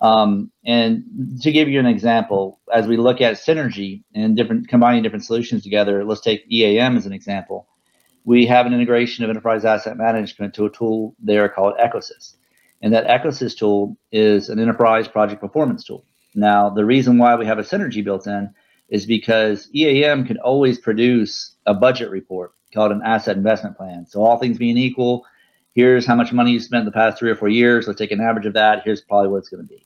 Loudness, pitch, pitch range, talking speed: -17 LUFS, 115 Hz, 105-120 Hz, 205 wpm